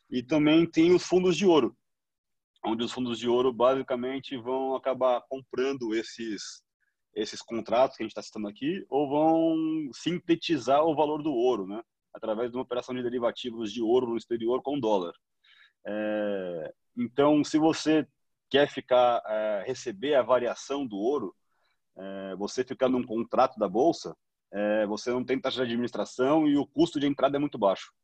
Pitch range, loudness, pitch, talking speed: 115-150 Hz, -27 LUFS, 130 Hz, 170 wpm